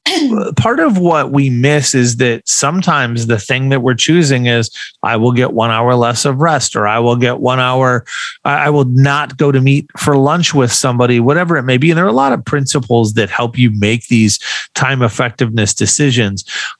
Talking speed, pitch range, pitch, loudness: 205 wpm, 120-145 Hz, 130 Hz, -12 LUFS